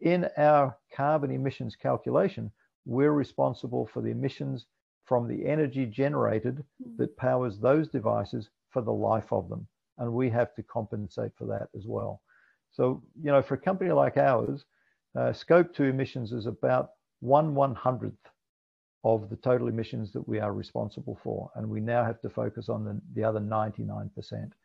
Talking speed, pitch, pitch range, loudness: 170 wpm, 125 Hz, 110-140 Hz, -29 LUFS